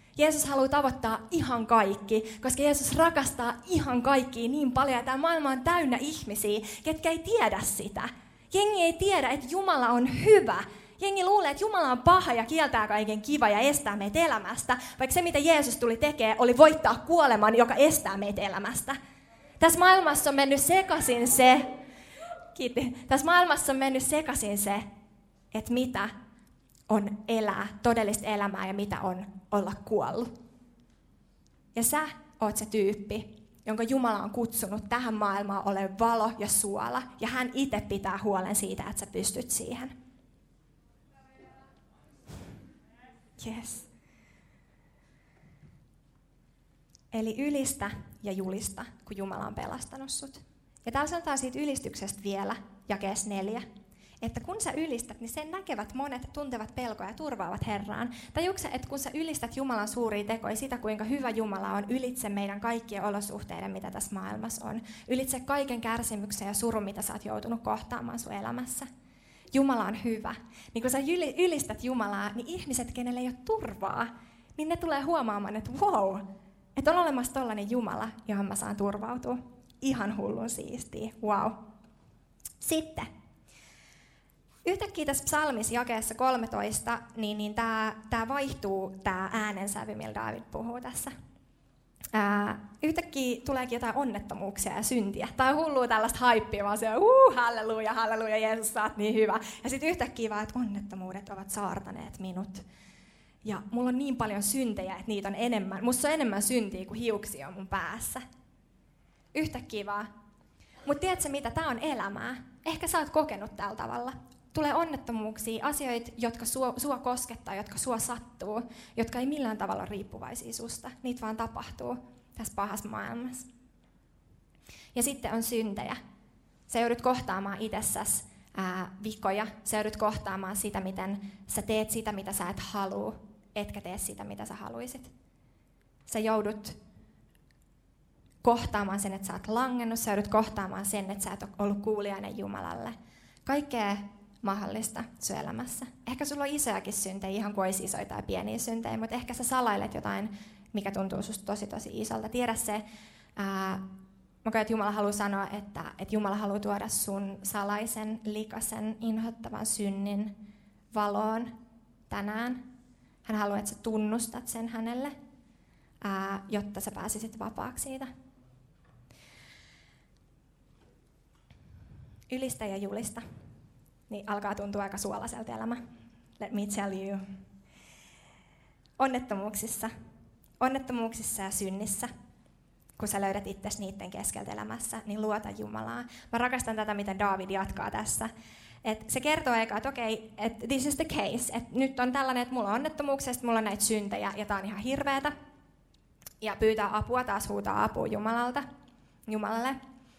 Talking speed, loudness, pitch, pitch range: 145 wpm, -30 LUFS, 225 Hz, 205-255 Hz